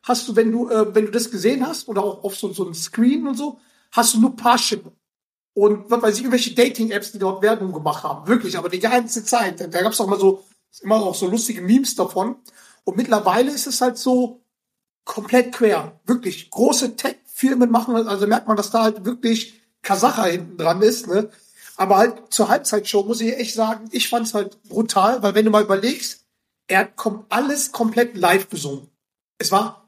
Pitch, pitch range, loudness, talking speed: 225 Hz, 200-240 Hz, -19 LUFS, 205 wpm